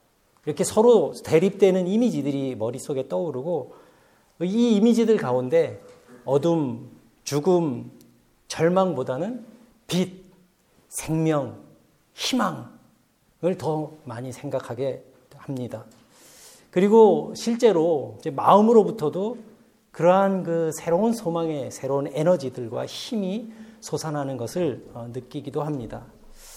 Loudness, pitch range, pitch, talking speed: -23 LUFS, 130-200 Hz, 160 Hz, 235 characters per minute